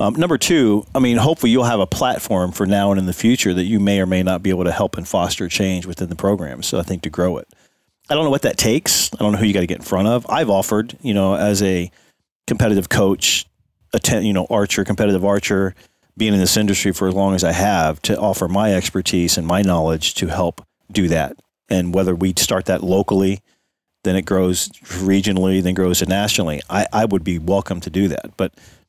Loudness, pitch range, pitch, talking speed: -18 LUFS, 90-100 Hz, 95 Hz, 235 wpm